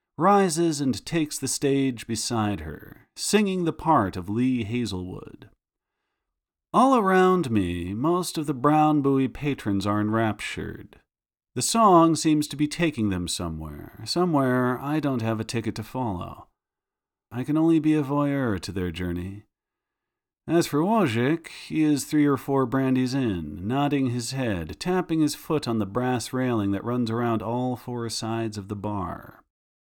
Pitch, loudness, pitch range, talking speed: 125 Hz, -24 LUFS, 110-155 Hz, 155 wpm